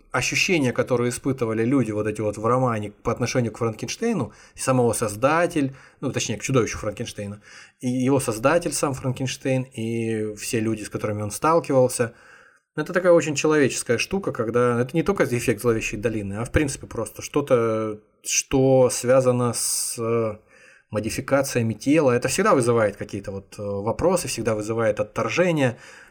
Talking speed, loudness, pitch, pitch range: 145 wpm, -23 LUFS, 120 Hz, 110-135 Hz